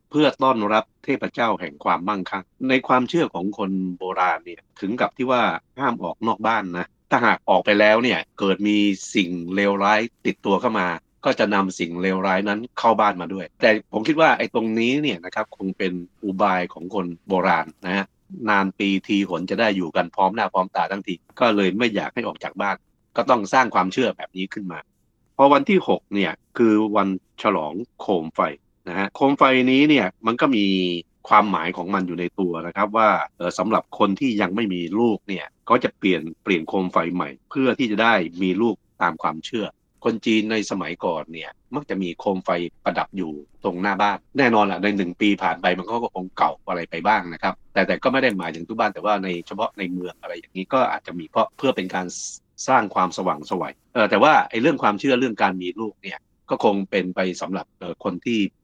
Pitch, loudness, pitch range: 100 Hz, -21 LUFS, 90-110 Hz